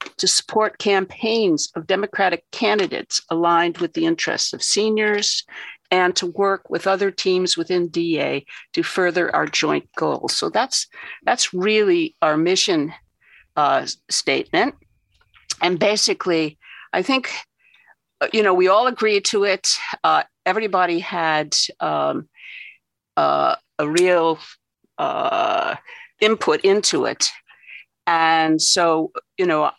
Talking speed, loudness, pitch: 120 wpm, -19 LUFS, 200 Hz